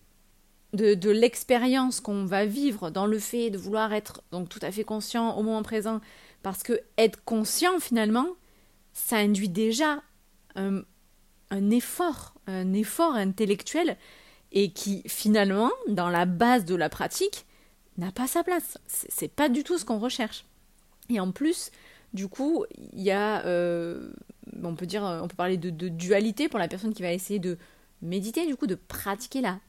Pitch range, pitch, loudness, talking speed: 195-250 Hz, 215 Hz, -27 LUFS, 175 wpm